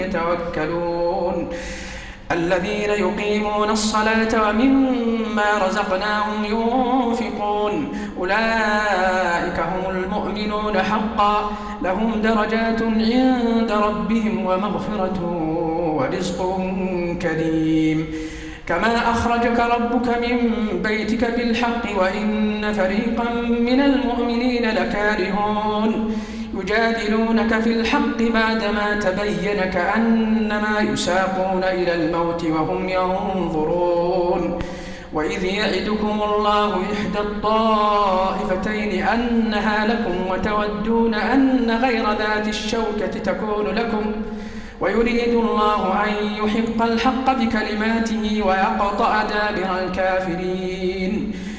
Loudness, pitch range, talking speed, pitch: -20 LUFS, 185-225 Hz, 75 wpm, 210 Hz